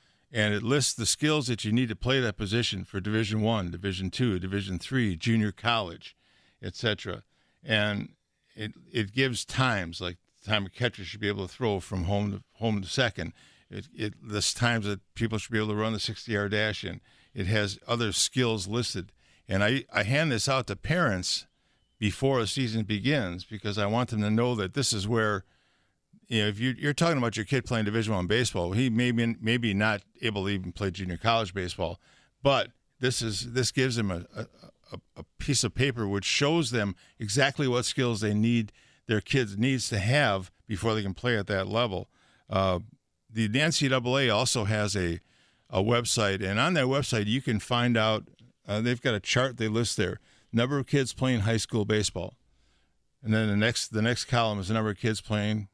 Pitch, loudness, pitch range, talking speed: 110 Hz, -28 LUFS, 100-125 Hz, 200 wpm